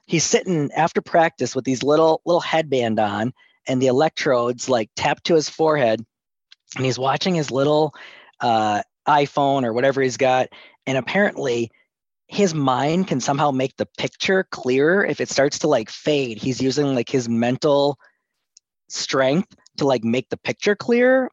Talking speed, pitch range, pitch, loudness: 160 wpm, 130-160 Hz, 140 Hz, -20 LUFS